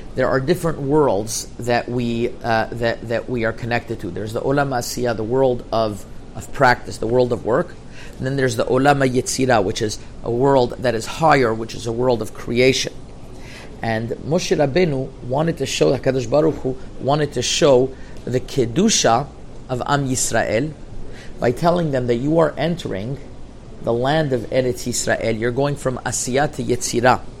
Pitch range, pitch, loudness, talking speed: 115-135 Hz, 125 Hz, -19 LUFS, 175 wpm